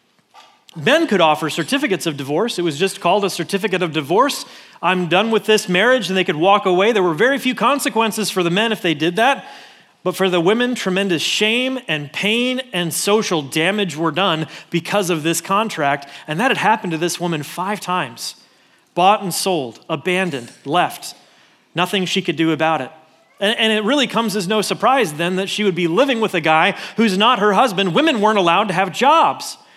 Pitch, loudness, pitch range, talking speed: 190 Hz, -17 LUFS, 170-215 Hz, 200 wpm